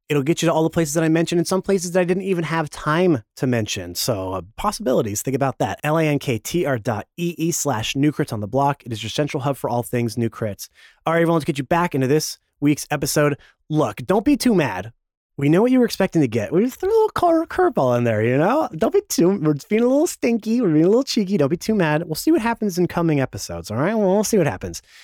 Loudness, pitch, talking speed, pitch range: -20 LUFS, 155 Hz, 285 wpm, 130-190 Hz